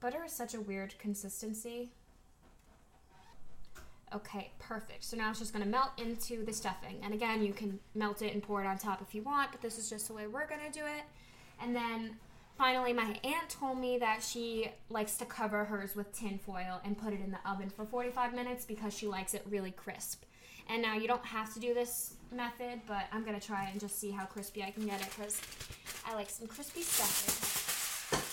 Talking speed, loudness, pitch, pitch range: 210 wpm, -38 LUFS, 215 Hz, 200-240 Hz